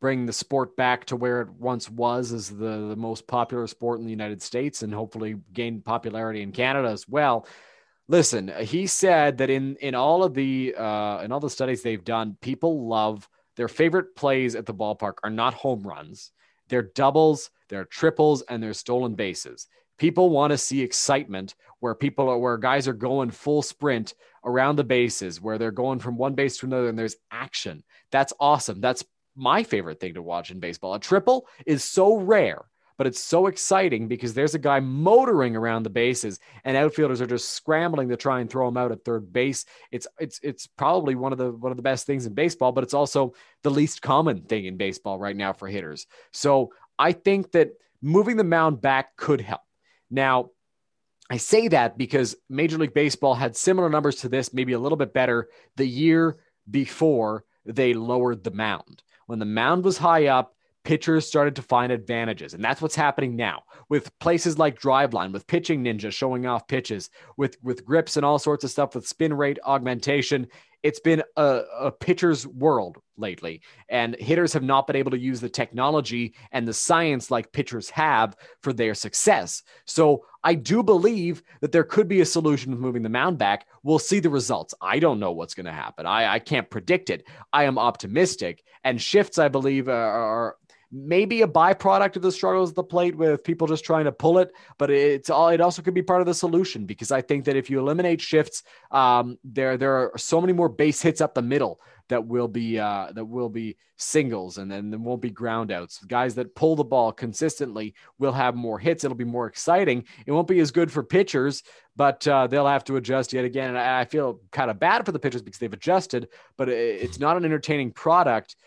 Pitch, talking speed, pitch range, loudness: 135 Hz, 205 wpm, 120-155 Hz, -24 LUFS